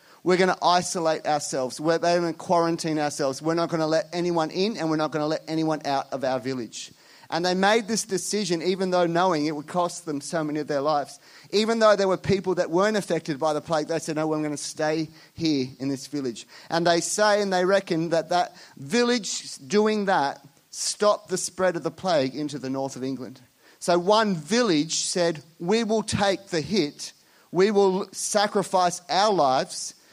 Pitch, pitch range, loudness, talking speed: 165 Hz, 150-190 Hz, -24 LUFS, 205 wpm